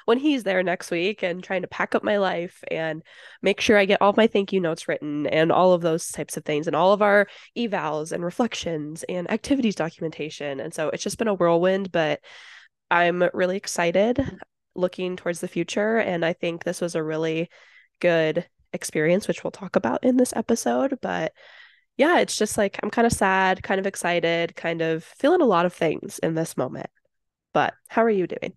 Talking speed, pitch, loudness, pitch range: 205 wpm, 180 Hz, -23 LUFS, 165-205 Hz